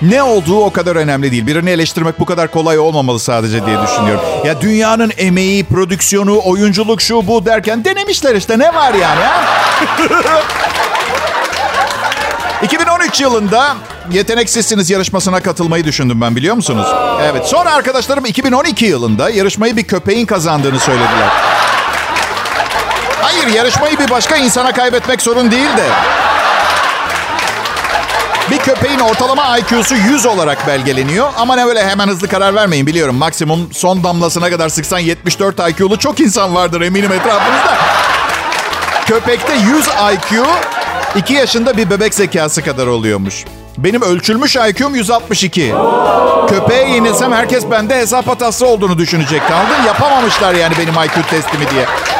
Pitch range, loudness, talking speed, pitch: 170-240 Hz, -11 LUFS, 130 wpm, 200 Hz